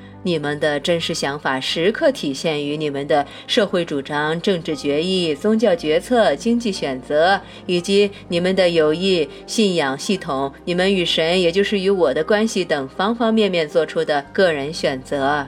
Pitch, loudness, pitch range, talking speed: 170 Hz, -19 LUFS, 150-200 Hz, 255 characters per minute